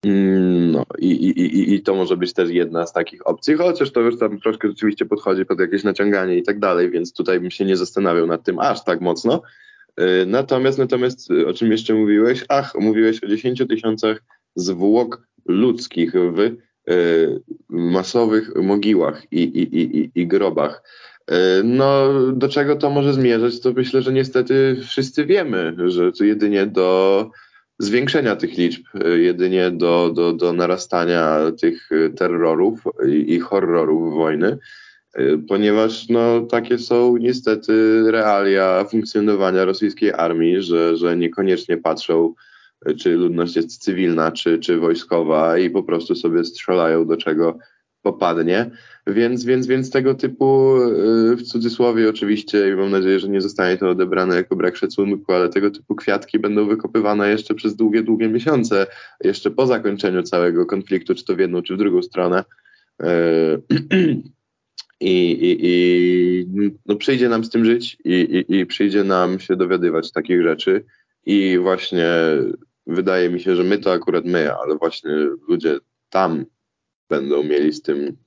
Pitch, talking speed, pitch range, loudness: 110 Hz, 150 wpm, 90-130 Hz, -18 LUFS